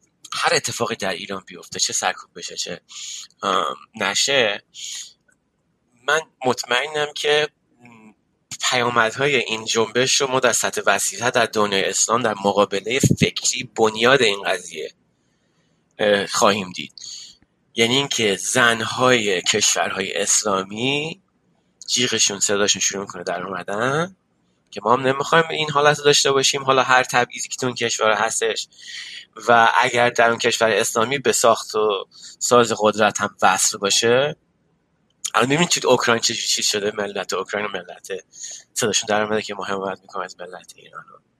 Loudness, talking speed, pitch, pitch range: -19 LUFS, 135 wpm, 115 Hz, 105-135 Hz